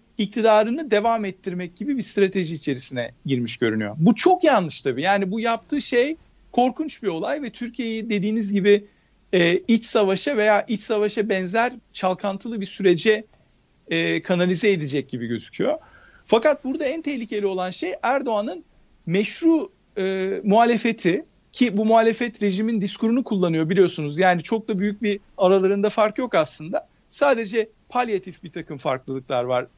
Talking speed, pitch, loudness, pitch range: 145 wpm, 205 Hz, -22 LUFS, 180-230 Hz